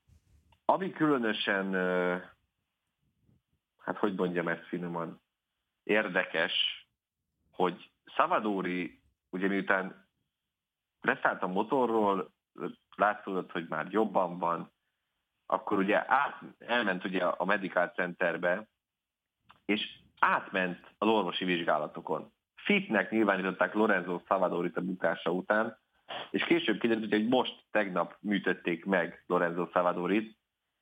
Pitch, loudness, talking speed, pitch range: 90 Hz, -31 LUFS, 95 wpm, 90-105 Hz